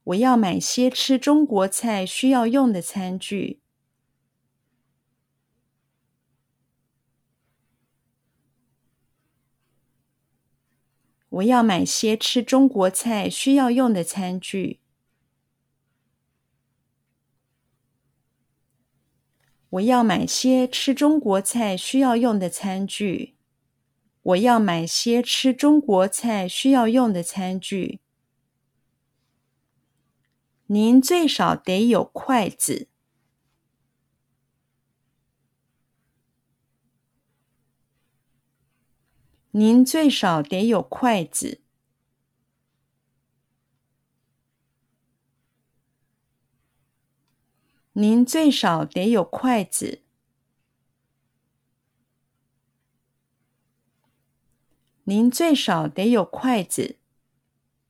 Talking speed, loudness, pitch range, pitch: 85 characters per minute, -20 LUFS, 130-200 Hz, 135 Hz